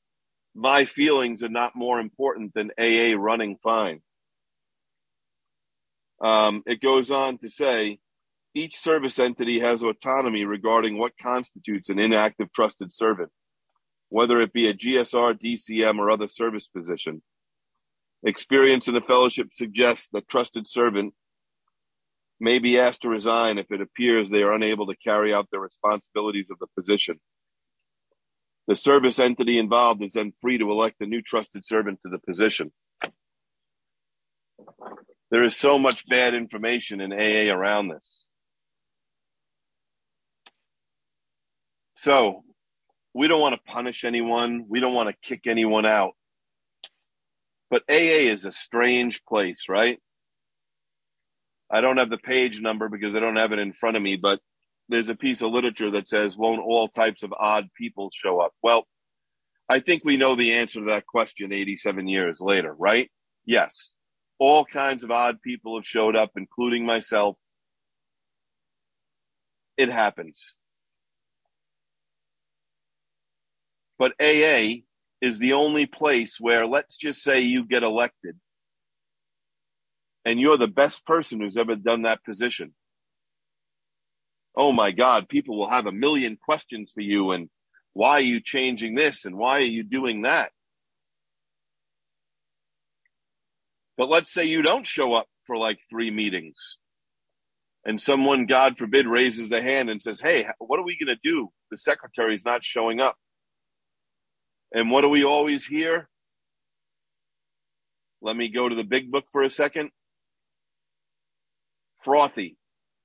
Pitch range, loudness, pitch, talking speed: 110-125 Hz, -23 LUFS, 115 Hz, 140 wpm